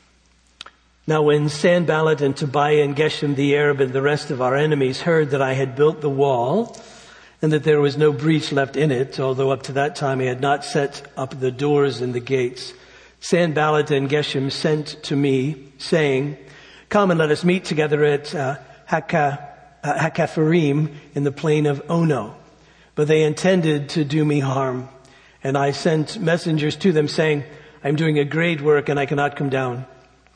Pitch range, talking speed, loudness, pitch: 135-155 Hz, 185 wpm, -20 LUFS, 145 Hz